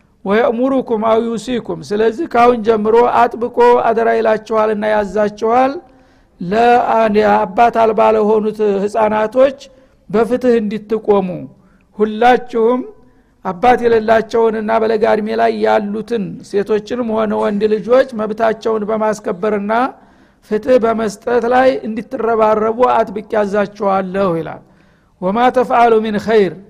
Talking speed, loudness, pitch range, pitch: 90 wpm, -14 LUFS, 215-235 Hz, 225 Hz